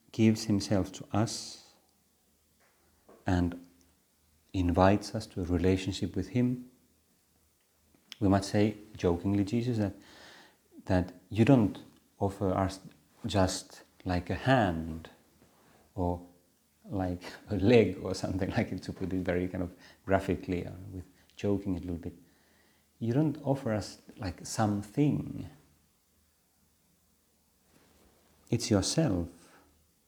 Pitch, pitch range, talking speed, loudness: 95 Hz, 85-105 Hz, 110 wpm, -31 LUFS